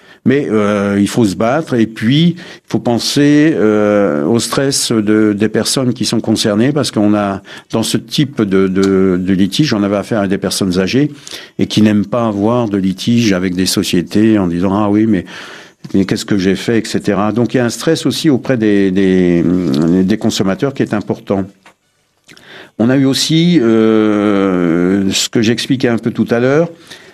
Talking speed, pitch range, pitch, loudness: 190 wpm, 100-120 Hz, 110 Hz, -13 LUFS